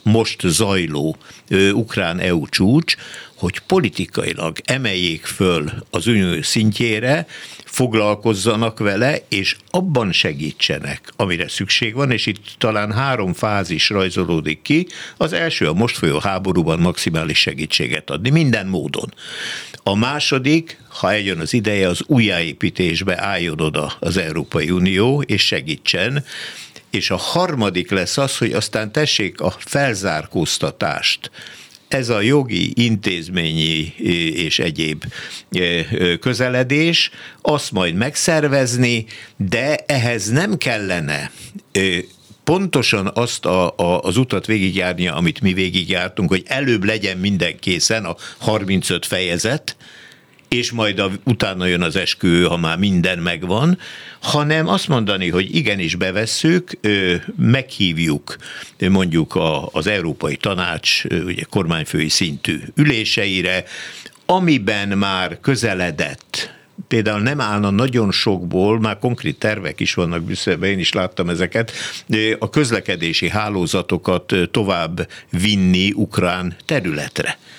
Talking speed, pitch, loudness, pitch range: 110 wpm, 105 Hz, -18 LUFS, 90-125 Hz